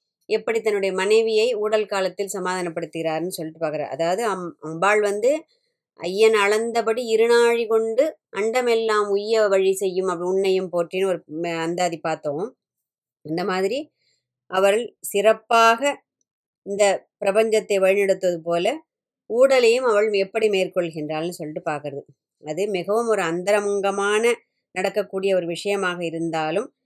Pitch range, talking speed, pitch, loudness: 175-225 Hz, 105 wpm, 195 Hz, -21 LUFS